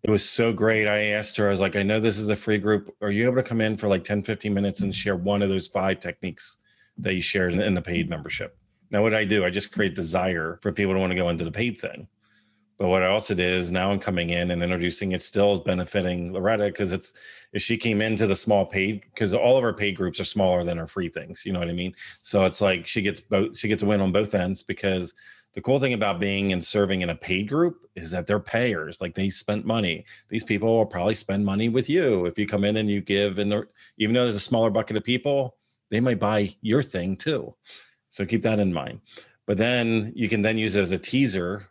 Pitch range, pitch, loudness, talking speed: 95-110 Hz, 100 Hz, -24 LUFS, 260 wpm